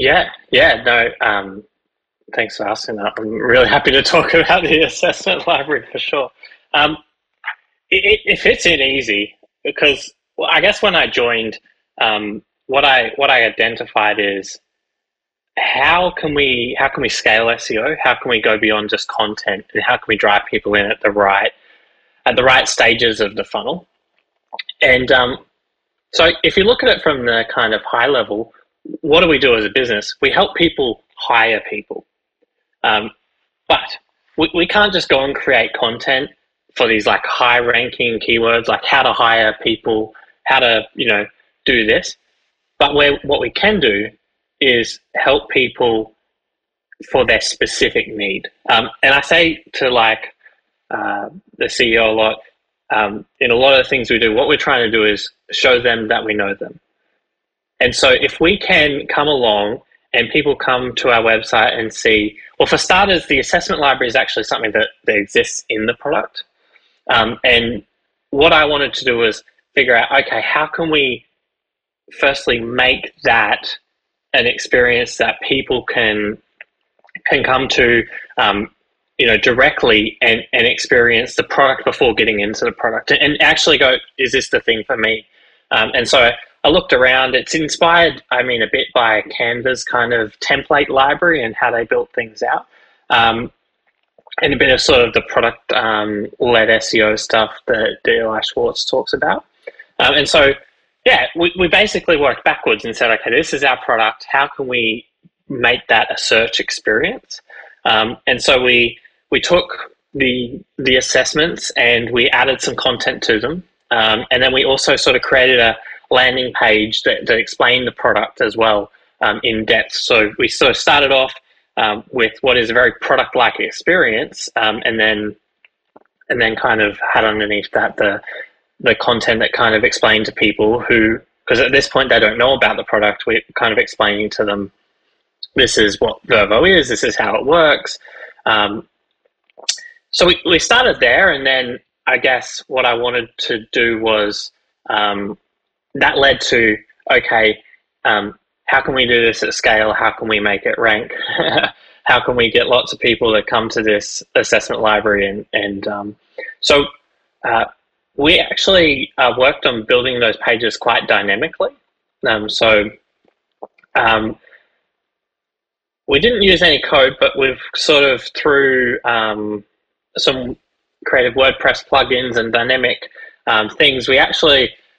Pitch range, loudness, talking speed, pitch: 110-175 Hz, -14 LUFS, 170 wpm, 125 Hz